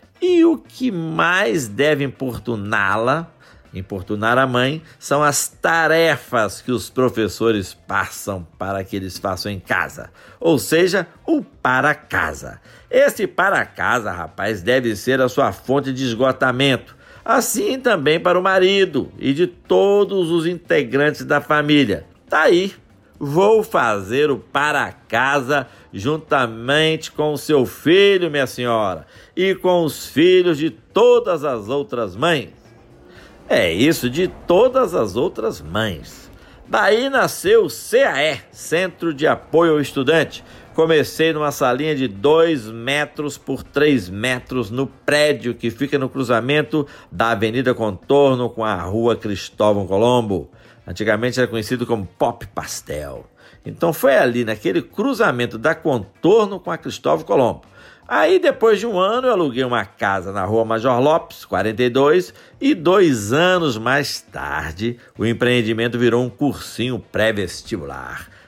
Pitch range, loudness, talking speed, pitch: 115-160 Hz, -18 LUFS, 135 wpm, 130 Hz